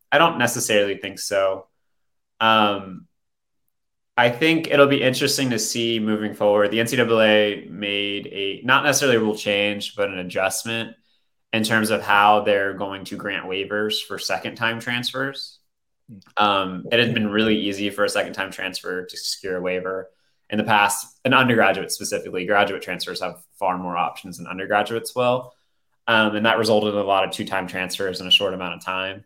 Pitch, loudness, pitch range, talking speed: 105 Hz, -21 LUFS, 95-115 Hz, 180 wpm